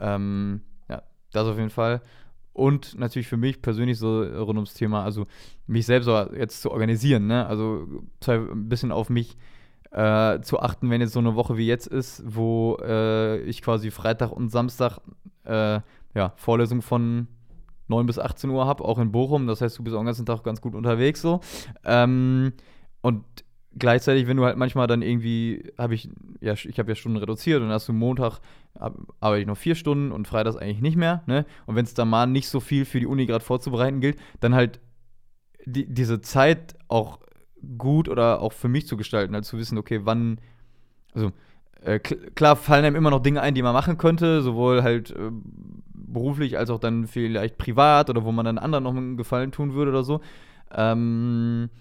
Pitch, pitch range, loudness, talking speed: 120 Hz, 110-130 Hz, -24 LUFS, 200 wpm